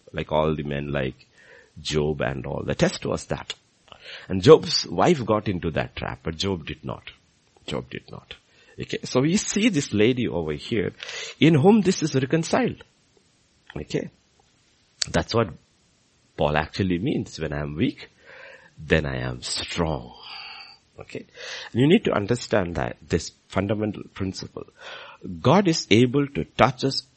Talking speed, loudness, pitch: 150 wpm, -23 LUFS, 95 Hz